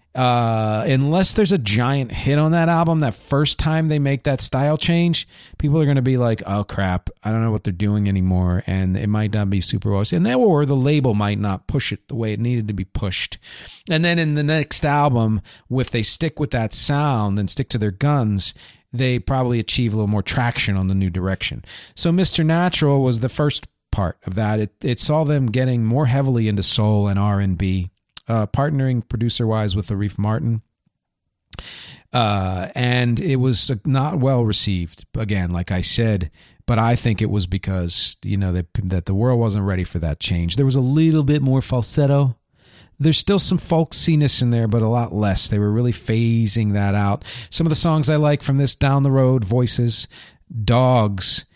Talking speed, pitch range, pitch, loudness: 205 wpm, 105-140 Hz, 120 Hz, -19 LUFS